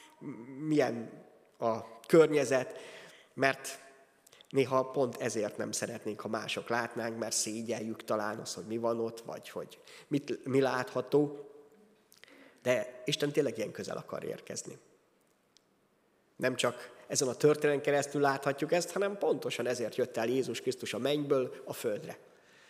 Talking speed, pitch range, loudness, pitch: 135 wpm, 115-145 Hz, -33 LUFS, 135 Hz